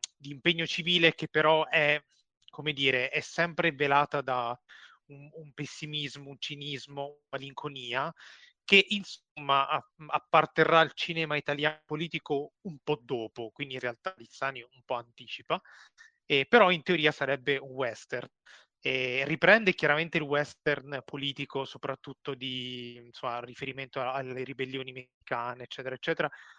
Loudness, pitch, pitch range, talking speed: -29 LUFS, 145 Hz, 135-160 Hz, 130 wpm